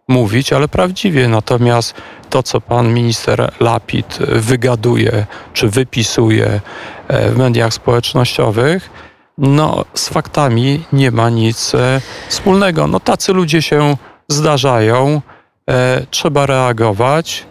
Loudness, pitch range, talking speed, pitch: -13 LUFS, 115-150 Hz, 105 wpm, 130 Hz